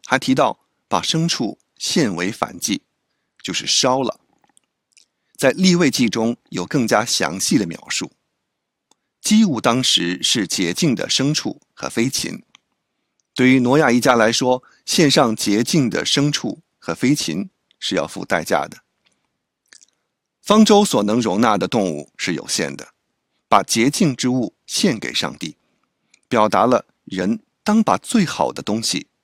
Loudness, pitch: -18 LUFS, 140 Hz